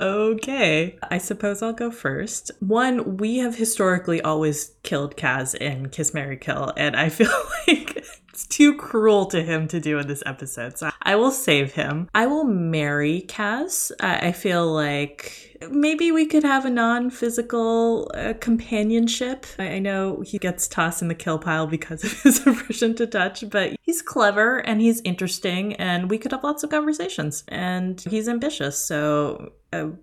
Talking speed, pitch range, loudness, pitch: 170 wpm, 160-235 Hz, -22 LUFS, 205 Hz